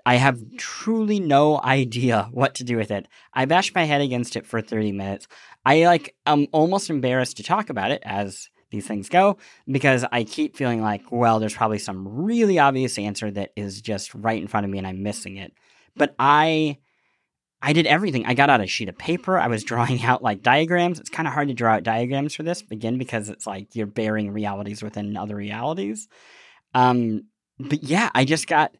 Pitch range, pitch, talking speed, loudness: 105-145 Hz, 120 Hz, 210 wpm, -22 LUFS